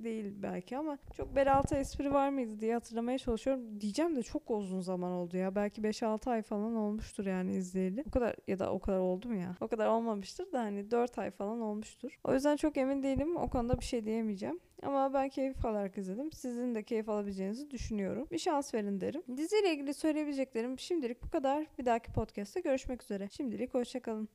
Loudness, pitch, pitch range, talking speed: -35 LUFS, 235 Hz, 210-275 Hz, 195 wpm